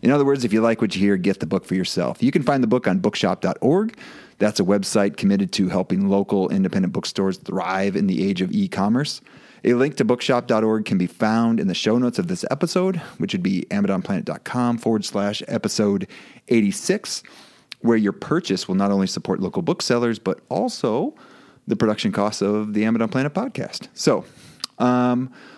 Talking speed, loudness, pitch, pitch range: 190 wpm, -21 LUFS, 110 Hz, 100-125 Hz